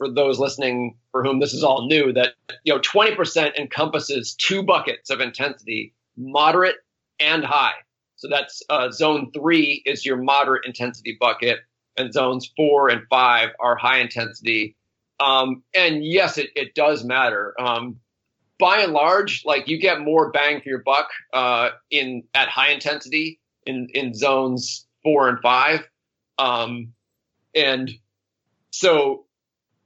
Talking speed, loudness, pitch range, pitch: 145 wpm, -20 LUFS, 120-145 Hz, 130 Hz